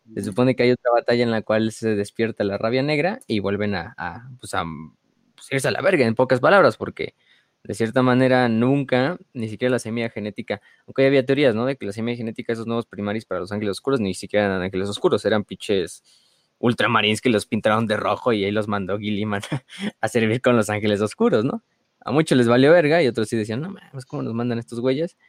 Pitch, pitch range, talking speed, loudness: 115 Hz, 105-130 Hz, 230 wpm, -21 LUFS